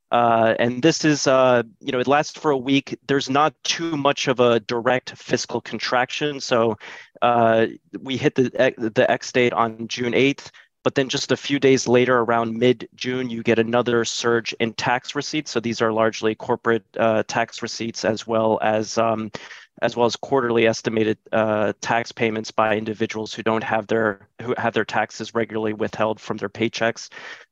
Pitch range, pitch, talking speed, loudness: 110-125 Hz, 115 Hz, 185 wpm, -21 LUFS